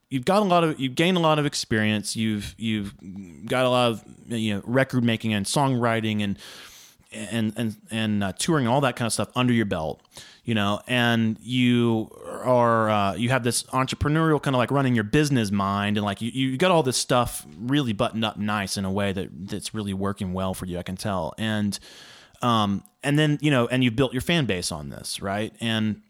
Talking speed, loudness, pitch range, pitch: 220 wpm, -24 LUFS, 105-130 Hz, 115 Hz